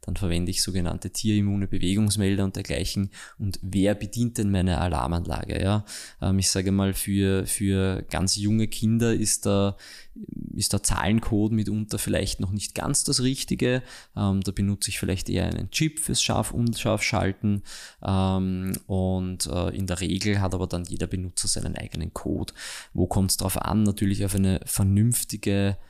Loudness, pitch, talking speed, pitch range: -25 LUFS, 100 Hz, 150 wpm, 95-105 Hz